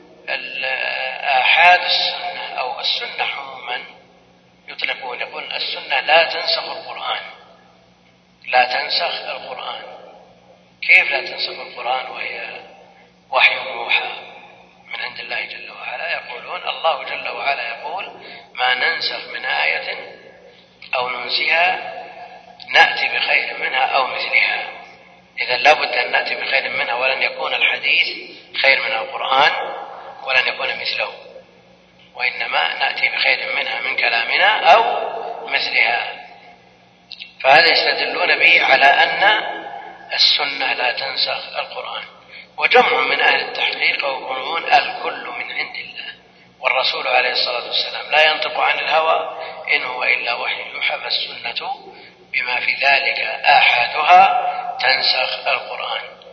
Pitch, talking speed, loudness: 365 Hz, 110 wpm, -17 LUFS